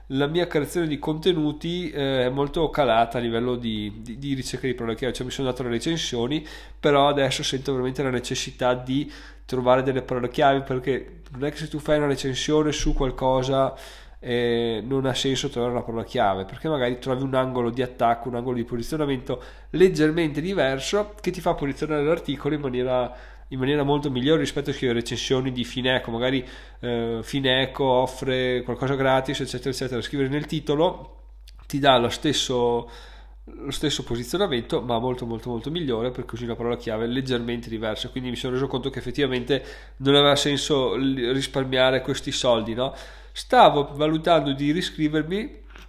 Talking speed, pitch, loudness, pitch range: 170 wpm, 130 Hz, -24 LUFS, 125-145 Hz